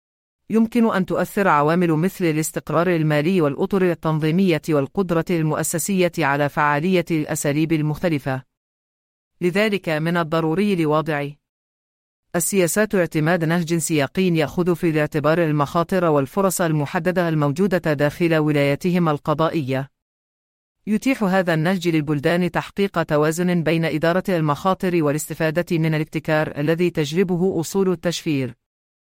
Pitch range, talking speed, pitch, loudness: 150-180 Hz, 100 wpm, 165 Hz, -20 LUFS